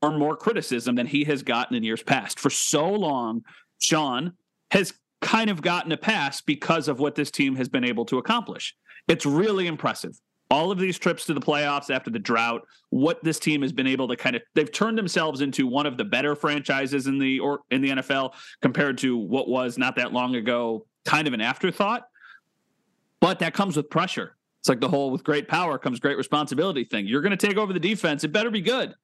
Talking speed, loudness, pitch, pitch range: 215 wpm, -24 LUFS, 150 Hz, 130-180 Hz